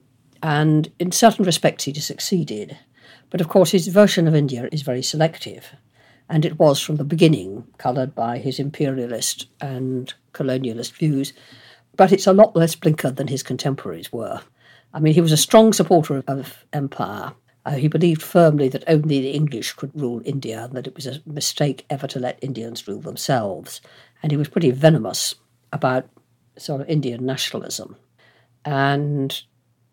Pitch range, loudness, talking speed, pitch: 125-155 Hz, -20 LUFS, 170 wpm, 140 Hz